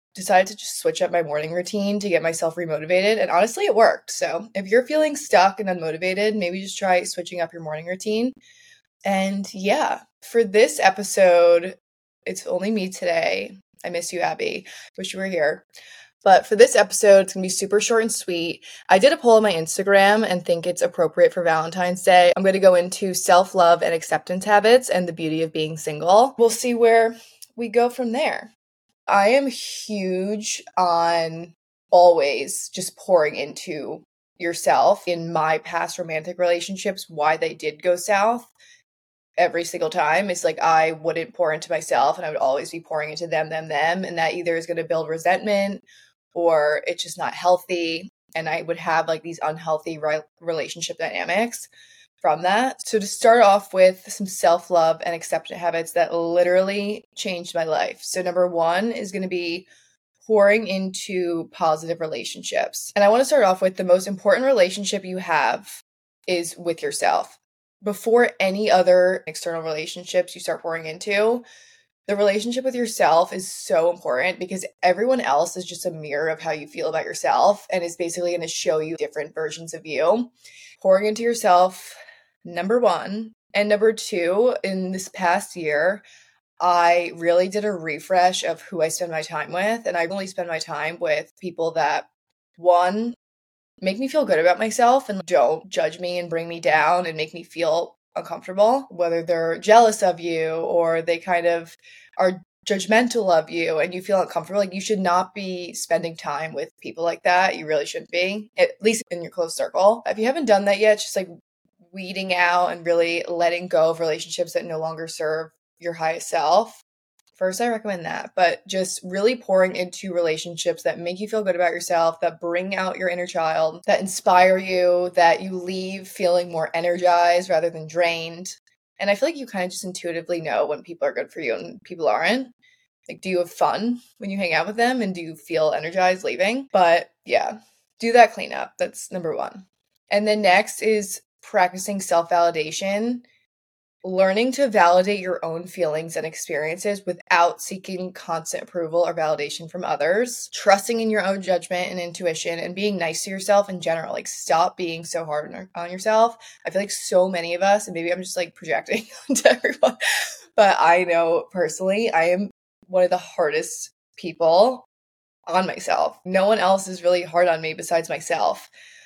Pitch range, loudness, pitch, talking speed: 170-205 Hz, -21 LUFS, 180 Hz, 185 wpm